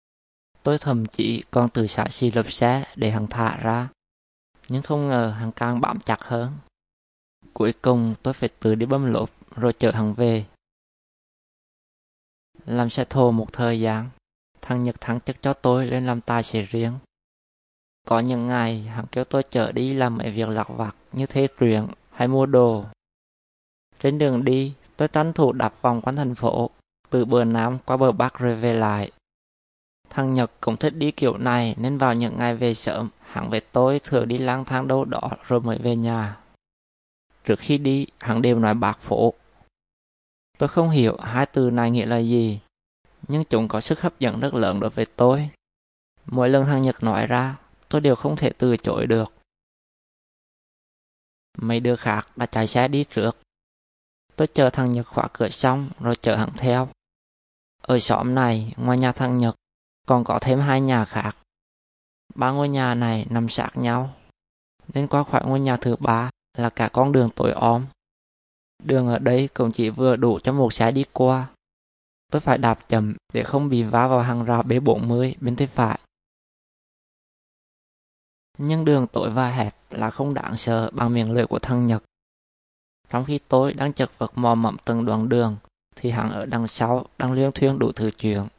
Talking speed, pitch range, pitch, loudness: 185 wpm, 110-130 Hz, 120 Hz, -22 LUFS